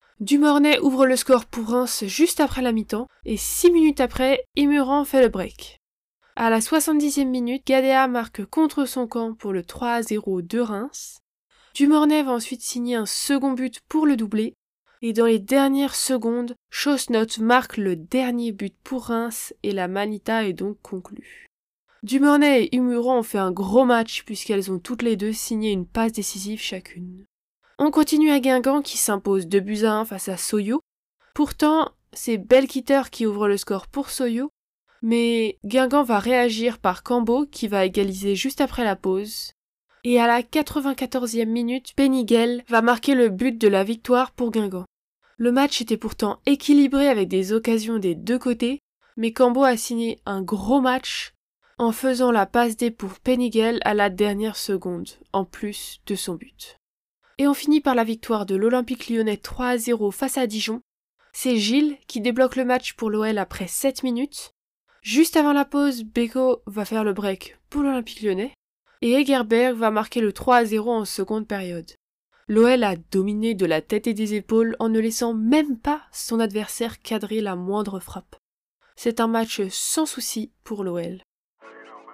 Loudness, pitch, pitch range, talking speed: -22 LUFS, 235 Hz, 210-260 Hz, 170 wpm